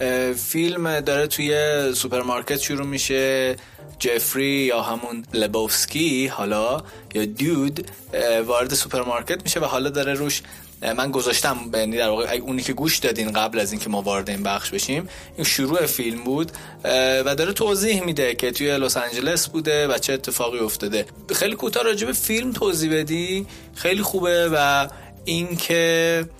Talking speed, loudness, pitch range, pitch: 150 wpm, -22 LUFS, 120-160 Hz, 135 Hz